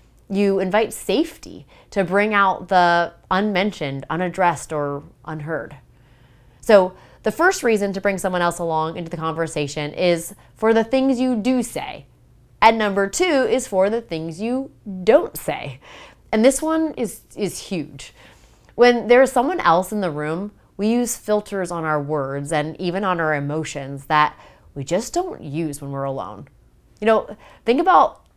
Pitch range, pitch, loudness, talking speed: 155-225 Hz, 185 Hz, -20 LUFS, 165 wpm